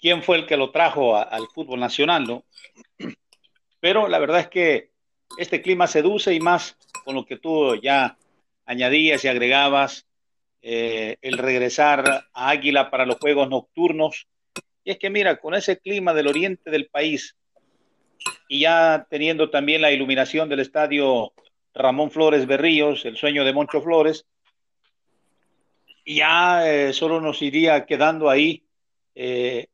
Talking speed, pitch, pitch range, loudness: 145 wpm, 150 Hz, 135-165 Hz, -20 LUFS